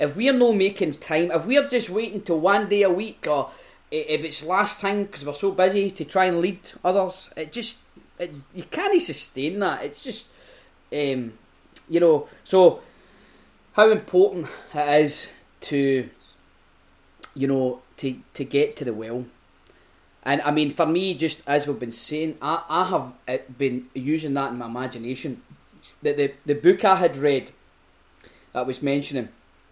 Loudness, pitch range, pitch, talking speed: -23 LUFS, 135-190 Hz, 155 Hz, 170 wpm